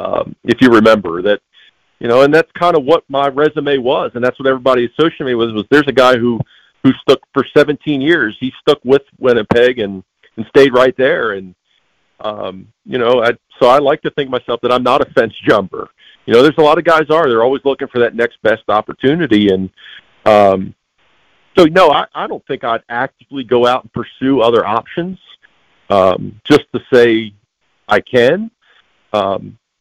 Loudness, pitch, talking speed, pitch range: -13 LUFS, 130 Hz, 195 wpm, 120-145 Hz